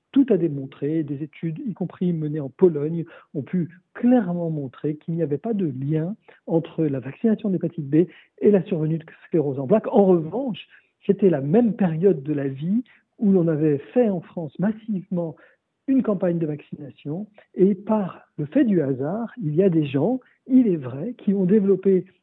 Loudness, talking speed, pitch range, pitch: -23 LUFS, 185 wpm, 155-205 Hz, 175 Hz